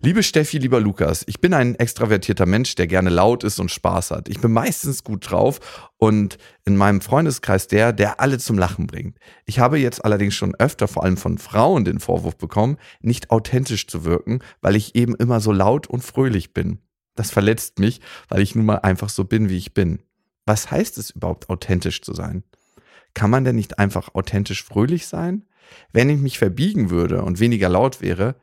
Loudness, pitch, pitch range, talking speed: -20 LUFS, 105 Hz, 95-120 Hz, 200 wpm